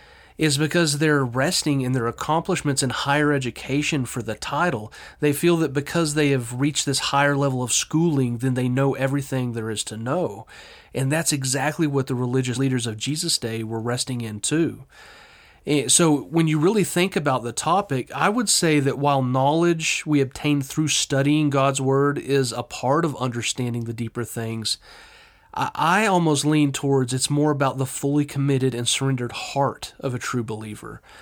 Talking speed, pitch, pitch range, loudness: 180 wpm, 140 Hz, 125-155 Hz, -22 LUFS